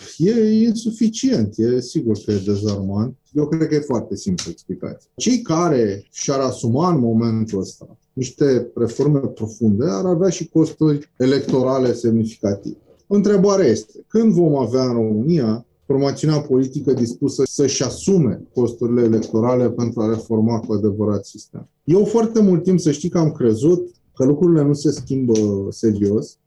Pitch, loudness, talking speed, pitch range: 130 Hz, -18 LUFS, 145 wpm, 115-160 Hz